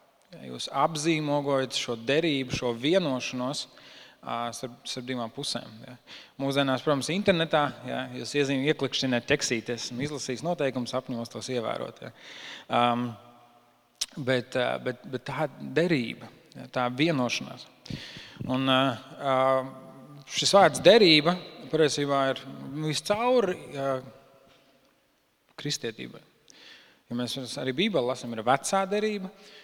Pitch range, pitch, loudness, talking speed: 125-145 Hz, 135 Hz, -27 LUFS, 90 wpm